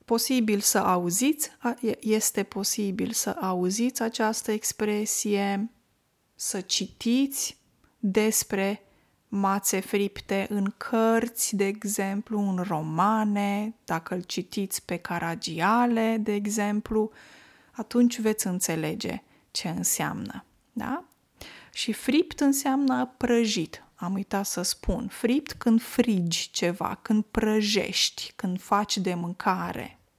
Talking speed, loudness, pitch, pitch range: 100 wpm, -27 LUFS, 210 Hz, 195-230 Hz